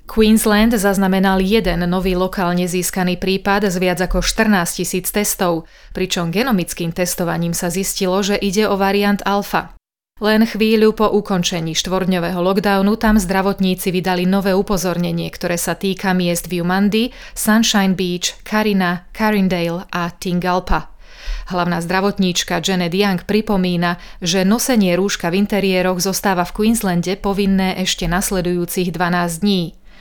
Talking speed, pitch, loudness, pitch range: 125 wpm, 190 Hz, -17 LUFS, 180-205 Hz